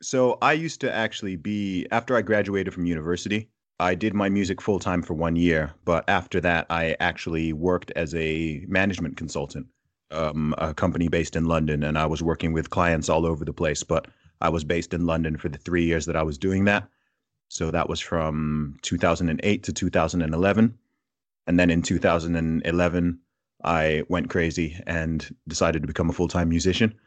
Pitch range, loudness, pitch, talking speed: 80-95 Hz, -25 LUFS, 85 Hz, 185 wpm